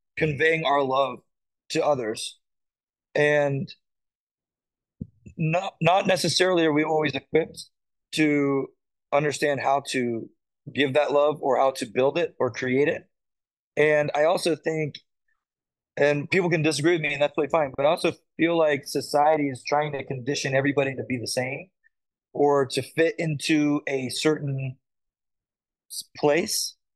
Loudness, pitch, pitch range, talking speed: -24 LUFS, 145 Hz, 135-160 Hz, 140 wpm